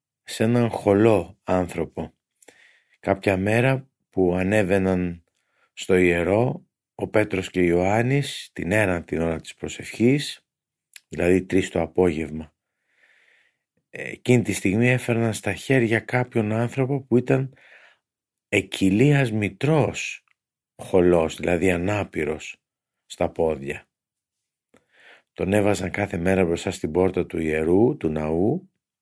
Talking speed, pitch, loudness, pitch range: 110 wpm, 95 Hz, -22 LUFS, 90-115 Hz